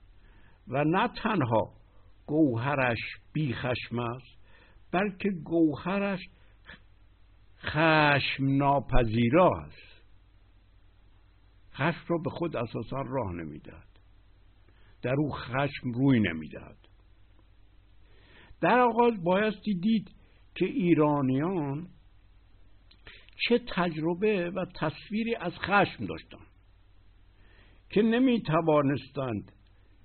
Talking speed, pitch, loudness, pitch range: 80 wpm, 120 Hz, -28 LUFS, 95-165 Hz